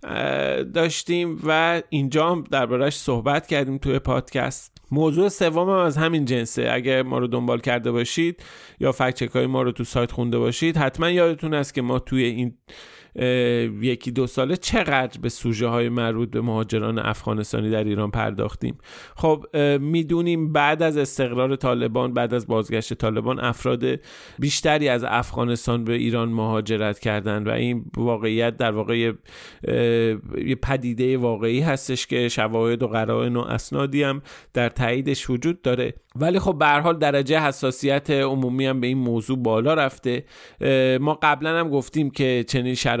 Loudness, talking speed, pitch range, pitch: -22 LUFS, 150 wpm, 120-145 Hz, 125 Hz